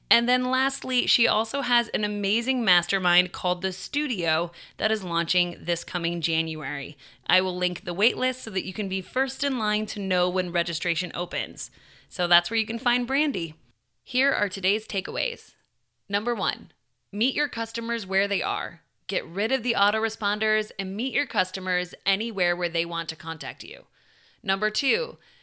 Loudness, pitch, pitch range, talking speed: -25 LUFS, 200 Hz, 175-235 Hz, 170 wpm